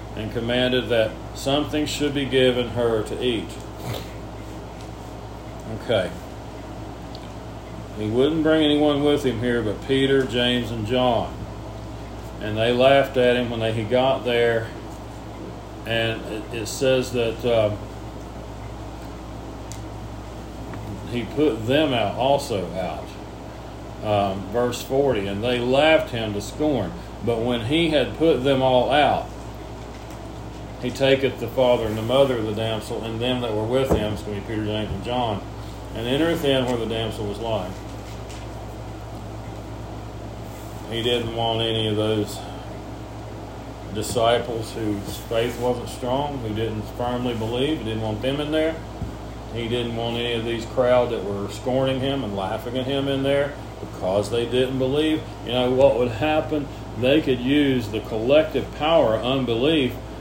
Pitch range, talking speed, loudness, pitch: 105-130 Hz, 145 wpm, -22 LUFS, 115 Hz